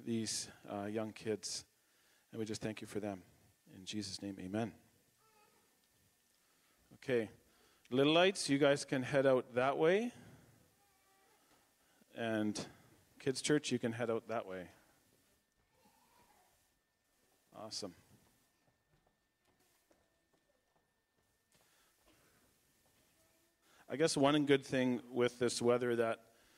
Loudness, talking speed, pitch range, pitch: -36 LUFS, 100 wpm, 110-135 Hz, 120 Hz